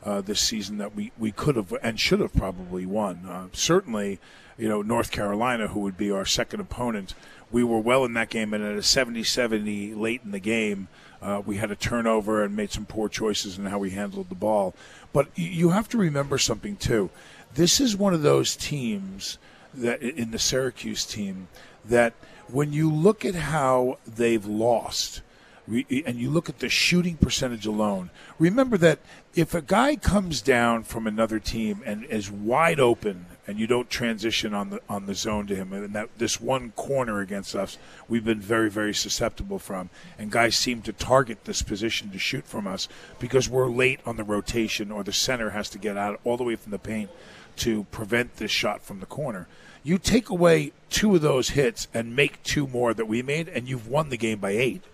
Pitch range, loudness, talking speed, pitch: 105-130 Hz, -25 LUFS, 205 wpm, 115 Hz